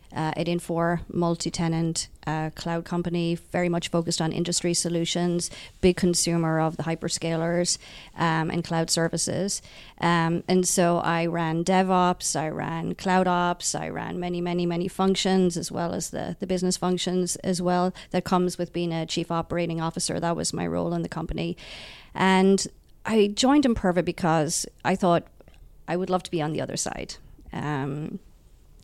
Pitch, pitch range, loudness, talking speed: 175 Hz, 165-180 Hz, -25 LUFS, 165 wpm